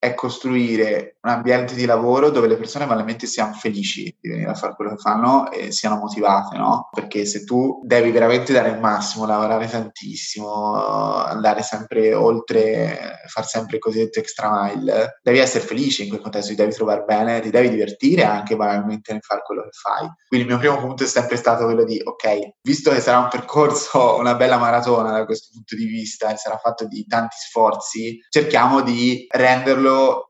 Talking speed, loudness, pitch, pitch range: 190 wpm, -19 LUFS, 115 Hz, 110-125 Hz